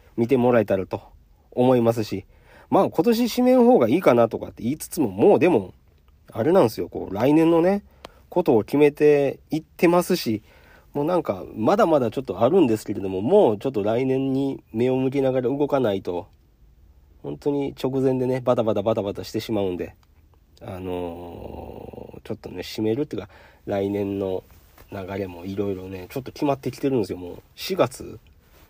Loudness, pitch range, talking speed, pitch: -22 LUFS, 95-135 Hz, 360 characters per minute, 115 Hz